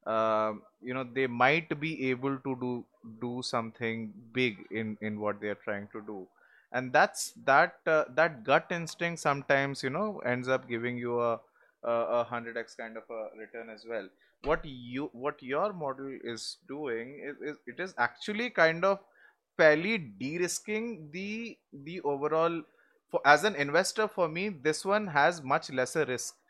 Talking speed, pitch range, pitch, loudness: 170 wpm, 115-165 Hz, 135 Hz, -31 LUFS